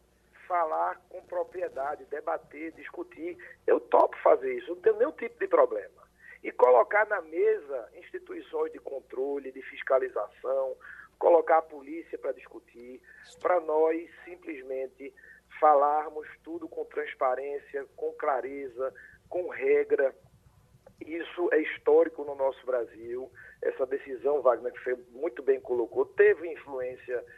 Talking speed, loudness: 125 wpm, -29 LUFS